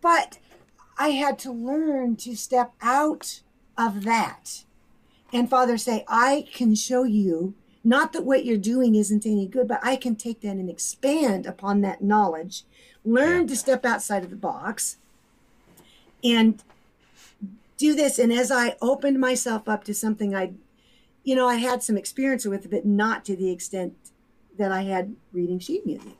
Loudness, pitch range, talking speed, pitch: -24 LUFS, 205-255 Hz, 165 wpm, 235 Hz